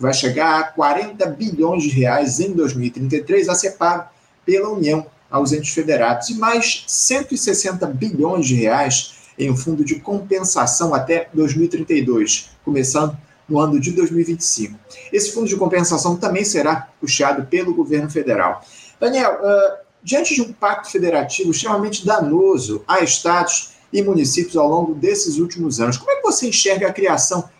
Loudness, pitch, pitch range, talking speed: -17 LUFS, 175 Hz, 150-205 Hz, 150 wpm